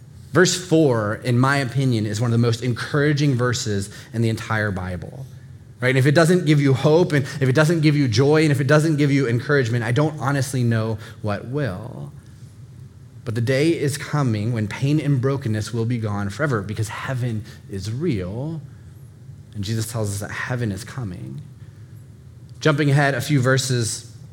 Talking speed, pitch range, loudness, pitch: 185 wpm, 115-140 Hz, -20 LUFS, 125 Hz